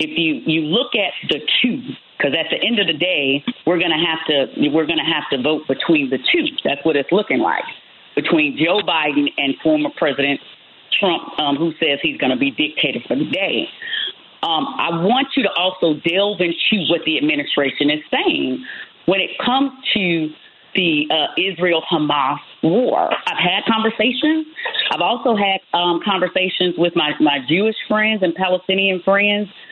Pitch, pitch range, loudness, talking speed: 180 Hz, 155-220 Hz, -17 LUFS, 175 wpm